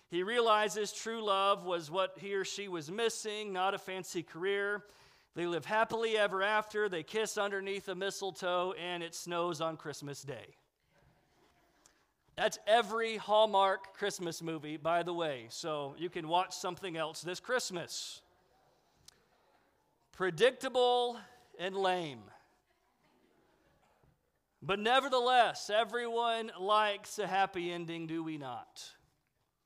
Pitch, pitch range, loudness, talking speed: 195 Hz, 175-215 Hz, -34 LUFS, 120 wpm